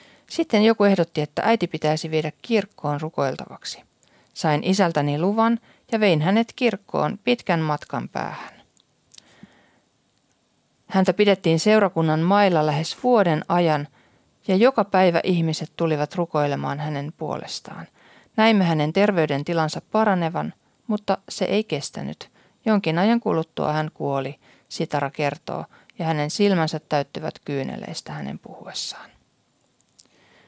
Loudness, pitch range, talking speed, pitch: -22 LUFS, 155-205 Hz, 110 wpm, 170 Hz